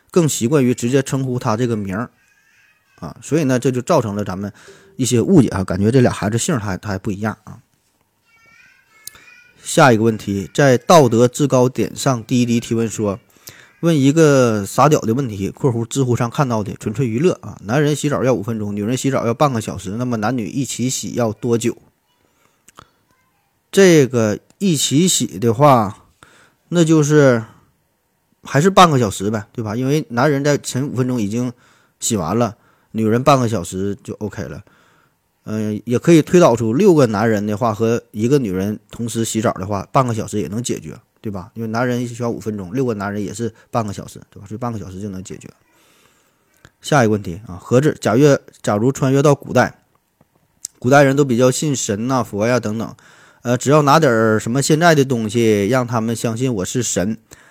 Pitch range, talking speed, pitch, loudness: 110-140 Hz, 280 characters per minute, 120 Hz, -17 LUFS